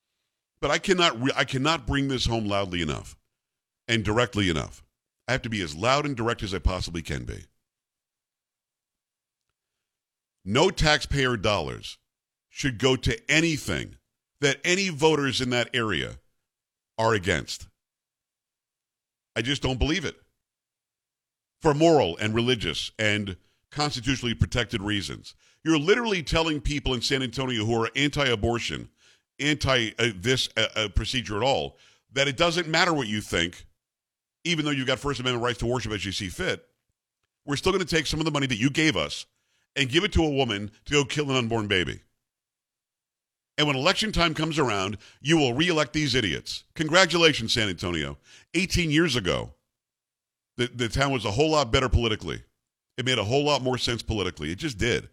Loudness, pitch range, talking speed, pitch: -25 LUFS, 105-150 Hz, 170 wpm, 130 Hz